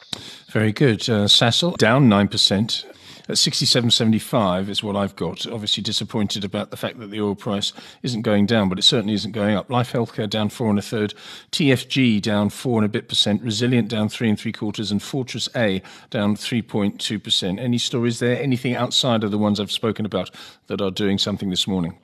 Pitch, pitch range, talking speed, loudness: 110 Hz, 105-120 Hz, 210 wpm, -20 LUFS